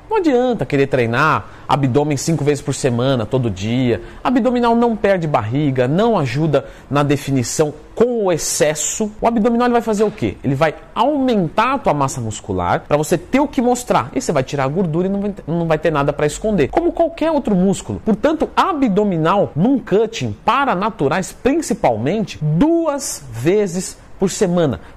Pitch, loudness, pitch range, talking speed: 170 Hz, -17 LUFS, 140-225 Hz, 170 wpm